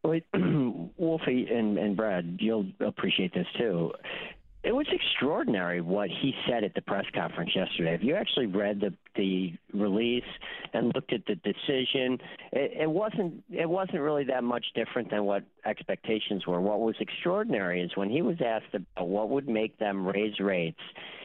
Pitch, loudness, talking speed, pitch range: 110 Hz, -30 LUFS, 170 wpm, 100-140 Hz